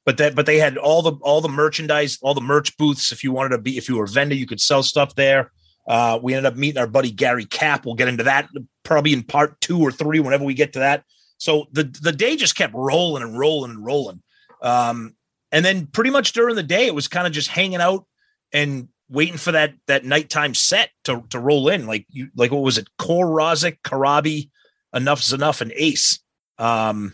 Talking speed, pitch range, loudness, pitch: 230 wpm, 130-155 Hz, -19 LUFS, 145 Hz